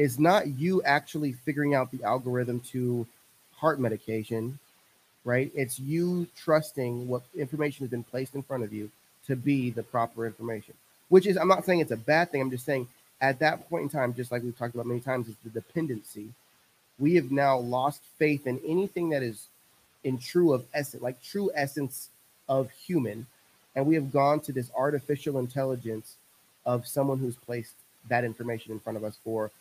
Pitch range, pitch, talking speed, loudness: 120-145 Hz, 130 Hz, 190 wpm, -29 LUFS